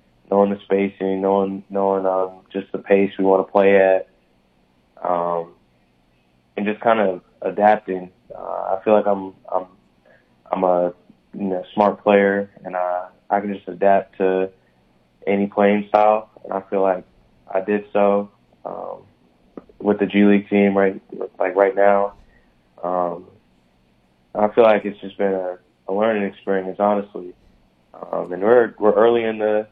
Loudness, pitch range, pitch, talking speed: -19 LUFS, 90-100 Hz, 95 Hz, 160 wpm